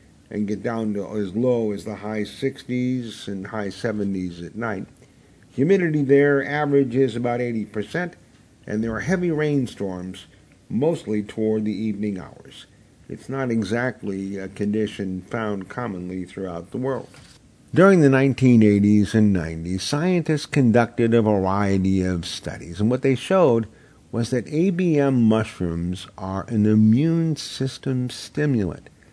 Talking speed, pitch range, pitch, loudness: 130 wpm, 100-130 Hz, 110 Hz, -22 LUFS